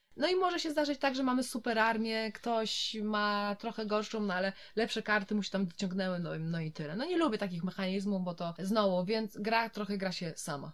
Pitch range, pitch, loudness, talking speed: 190-225 Hz, 210 Hz, -33 LUFS, 230 wpm